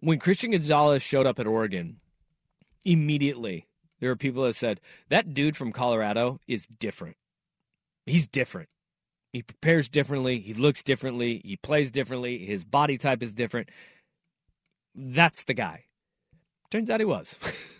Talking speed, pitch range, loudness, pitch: 140 wpm, 120-160 Hz, -26 LUFS, 140 Hz